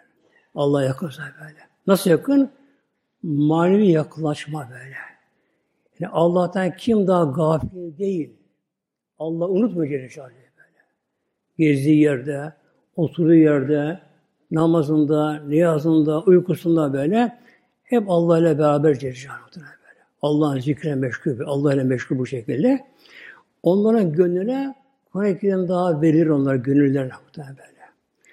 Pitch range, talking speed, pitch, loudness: 145-185 Hz, 100 wpm, 160 Hz, -20 LUFS